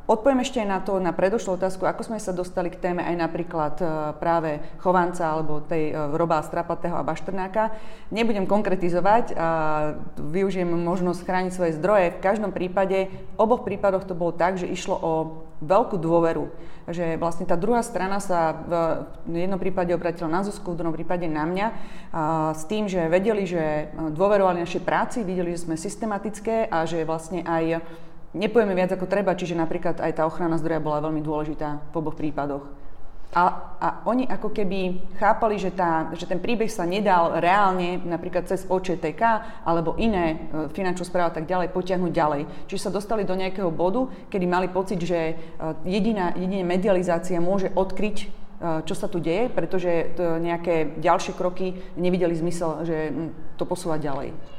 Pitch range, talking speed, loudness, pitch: 165-195 Hz, 165 wpm, -25 LUFS, 175 Hz